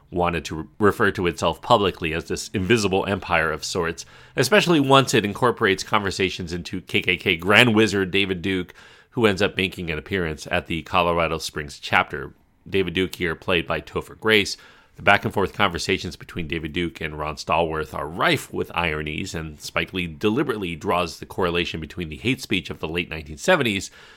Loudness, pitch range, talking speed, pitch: -22 LUFS, 80-100 Hz, 180 wpm, 90 Hz